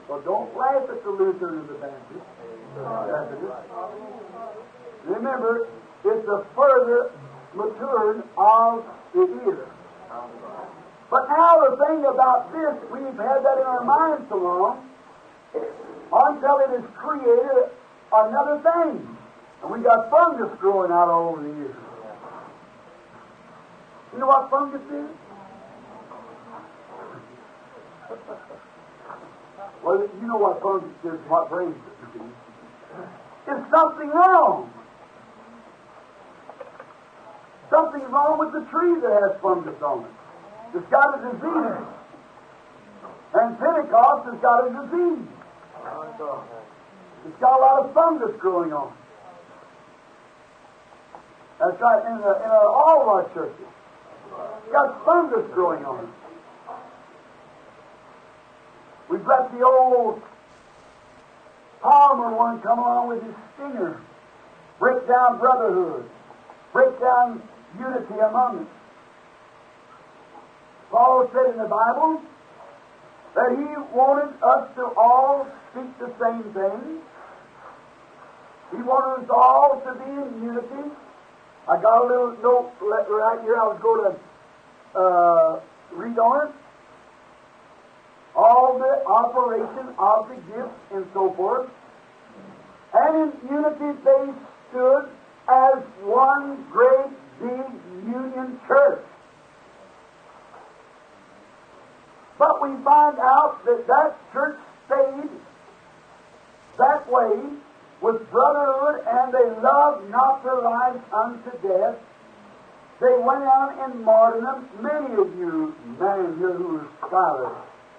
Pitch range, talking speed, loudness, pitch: 235-310 Hz, 110 wpm, -20 LUFS, 265 Hz